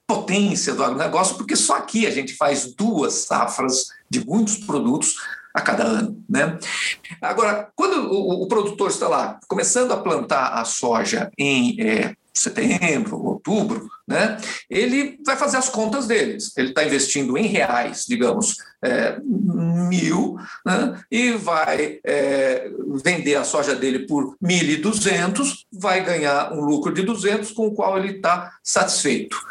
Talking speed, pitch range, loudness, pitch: 150 wpm, 155-225 Hz, -21 LUFS, 205 Hz